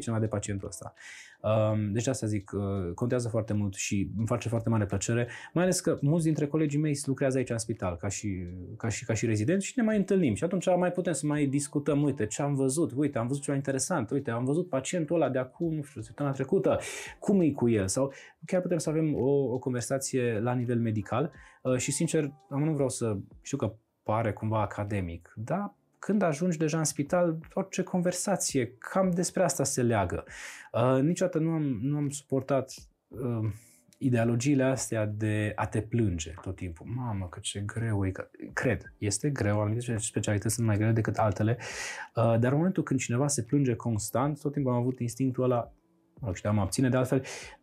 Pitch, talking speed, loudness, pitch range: 125 Hz, 195 wpm, -29 LUFS, 110-150 Hz